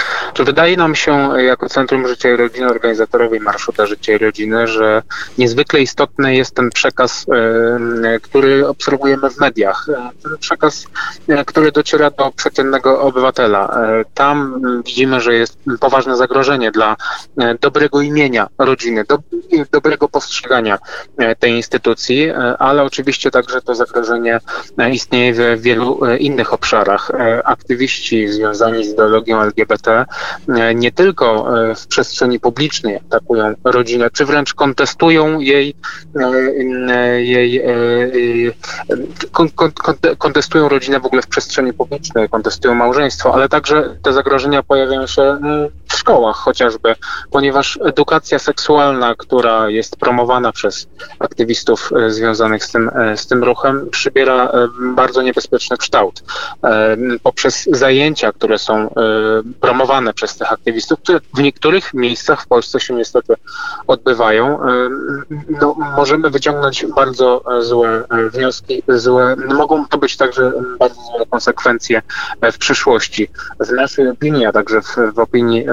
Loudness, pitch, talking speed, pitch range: -13 LUFS, 130 Hz, 120 wpm, 120-140 Hz